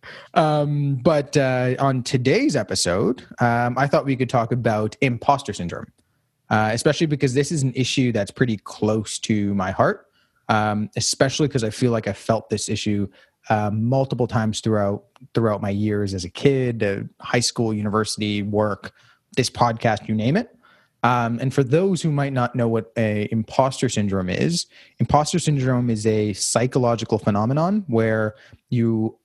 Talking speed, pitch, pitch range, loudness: 160 wpm, 120 Hz, 105-135 Hz, -21 LUFS